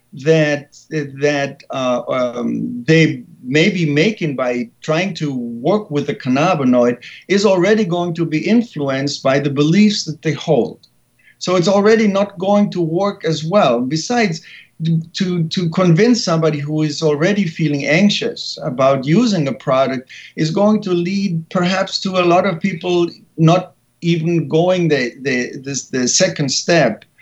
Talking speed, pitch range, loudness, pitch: 150 wpm, 145-190 Hz, -16 LUFS, 165 Hz